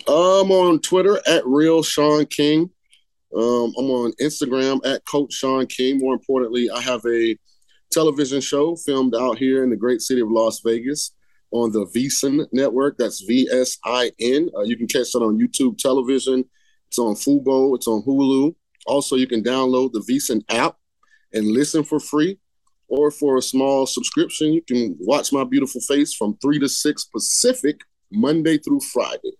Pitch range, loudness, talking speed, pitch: 125-155 Hz, -19 LUFS, 175 wpm, 135 Hz